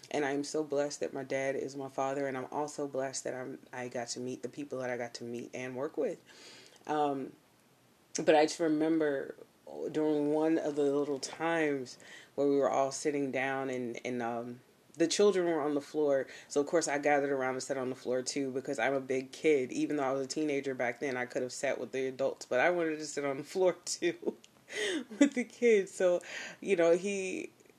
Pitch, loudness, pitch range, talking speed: 140 Hz, -33 LUFS, 130-160 Hz, 225 wpm